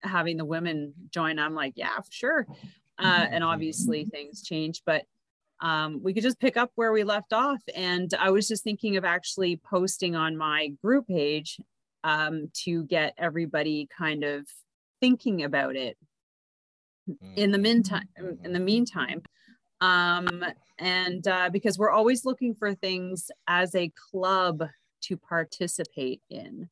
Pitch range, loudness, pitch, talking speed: 160-205 Hz, -27 LUFS, 180 Hz, 150 wpm